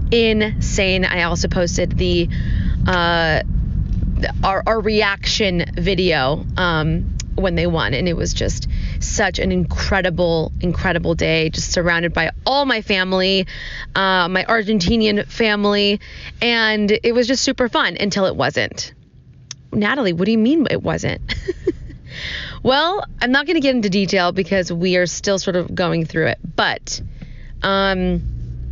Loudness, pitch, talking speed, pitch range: -18 LUFS, 185 Hz, 140 wpm, 165-215 Hz